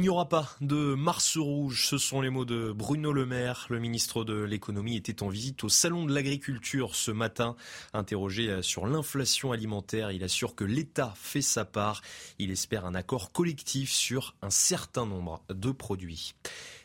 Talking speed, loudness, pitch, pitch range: 180 wpm, -30 LUFS, 120 Hz, 105-140 Hz